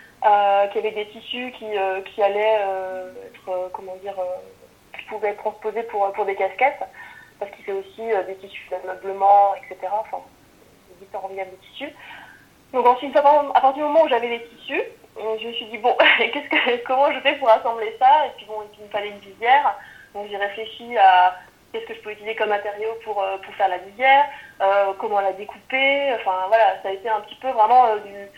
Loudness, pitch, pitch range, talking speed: -20 LUFS, 215 Hz, 195-245 Hz, 215 wpm